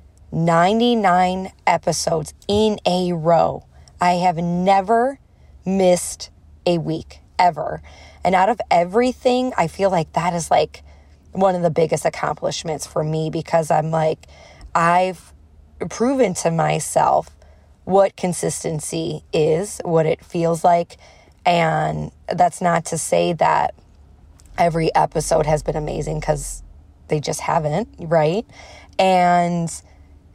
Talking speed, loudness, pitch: 120 wpm, -19 LUFS, 165 Hz